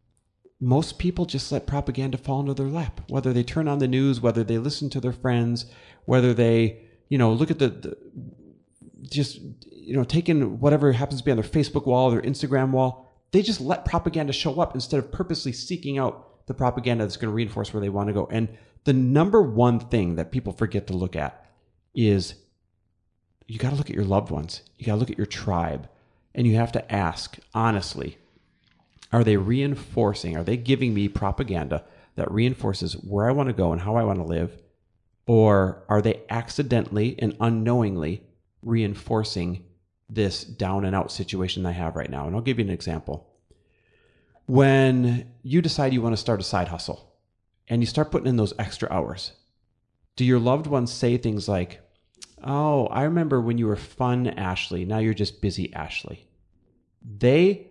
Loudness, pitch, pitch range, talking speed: -24 LUFS, 115 Hz, 100-135 Hz, 190 wpm